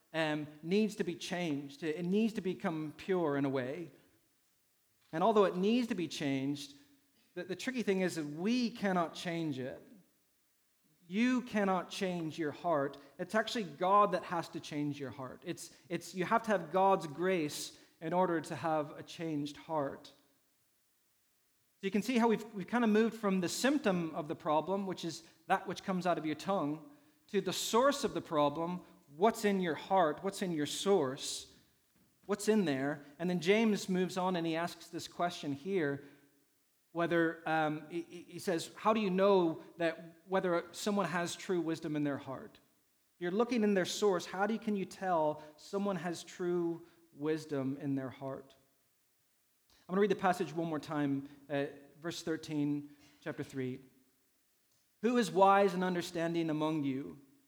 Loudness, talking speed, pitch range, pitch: -35 LUFS, 175 wpm, 150-195 Hz, 170 Hz